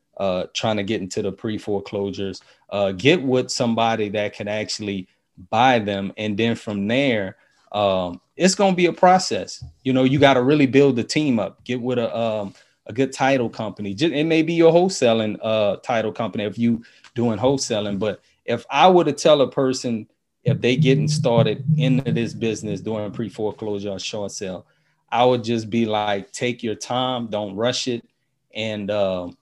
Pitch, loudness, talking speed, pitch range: 115 Hz, -21 LUFS, 185 wpm, 105-135 Hz